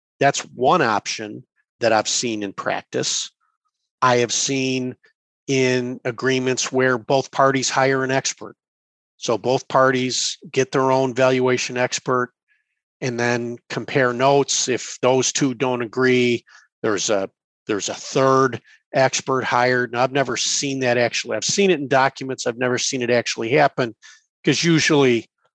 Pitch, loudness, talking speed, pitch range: 130 Hz, -20 LUFS, 145 wpm, 125-135 Hz